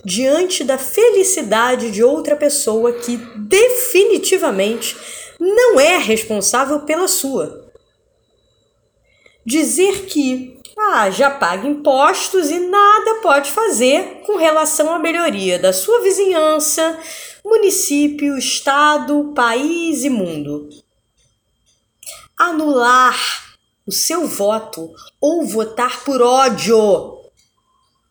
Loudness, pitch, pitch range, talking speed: -15 LUFS, 295 Hz, 245-365 Hz, 90 wpm